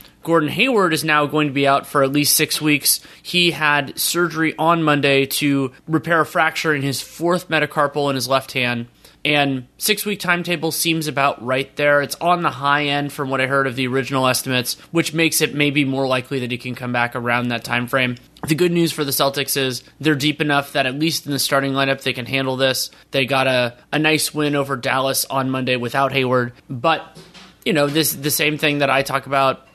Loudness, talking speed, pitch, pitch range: -18 LUFS, 220 wpm, 140 Hz, 135-155 Hz